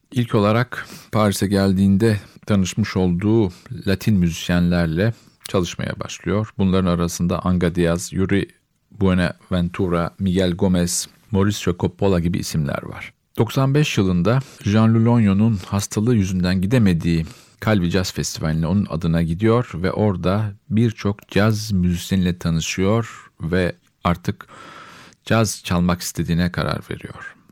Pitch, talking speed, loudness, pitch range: 95 Hz, 105 wpm, -20 LUFS, 90-110 Hz